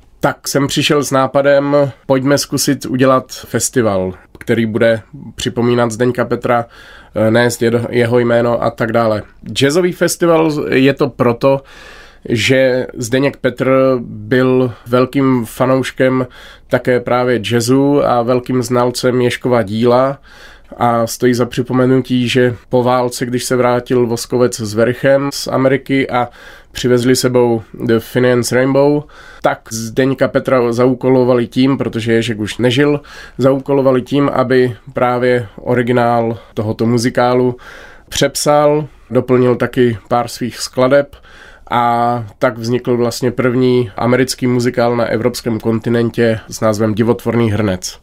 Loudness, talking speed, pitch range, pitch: -14 LUFS, 120 wpm, 120-130 Hz, 125 Hz